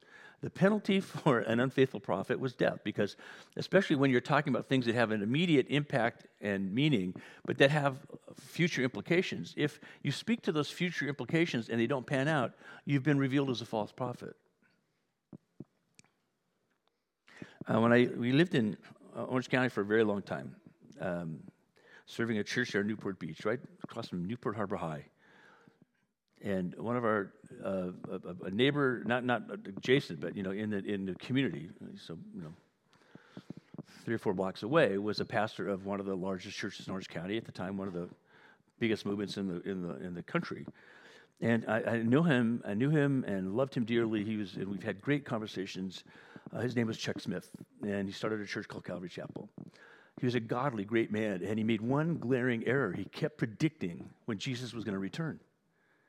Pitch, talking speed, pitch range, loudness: 120 Hz, 190 wpm, 100-140 Hz, -33 LUFS